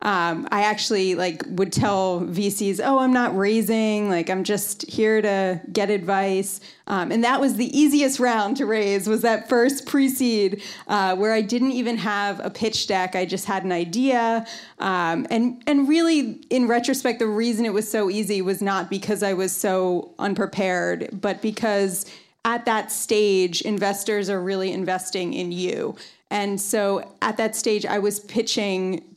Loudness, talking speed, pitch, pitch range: -22 LUFS, 170 wpm, 205 Hz, 195-230 Hz